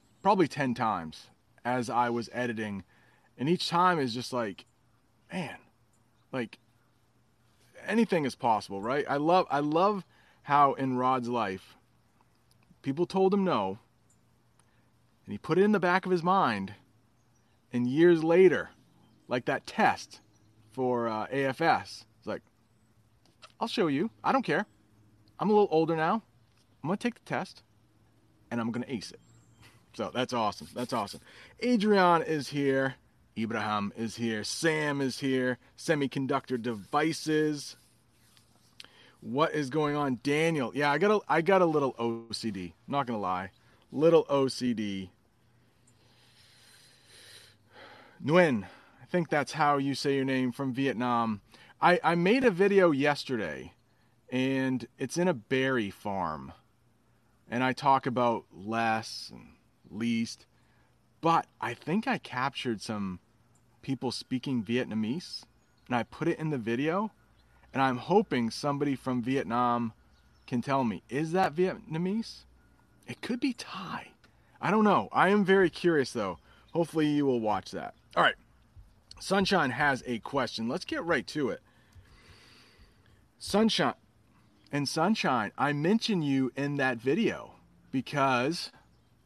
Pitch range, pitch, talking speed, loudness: 115-155 Hz, 125 Hz, 140 wpm, -29 LUFS